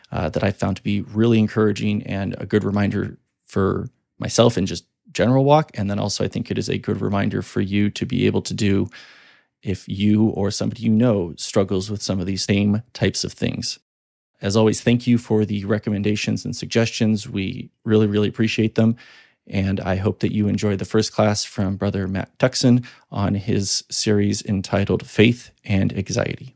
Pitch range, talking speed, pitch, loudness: 100-115 Hz, 190 wpm, 105 Hz, -21 LUFS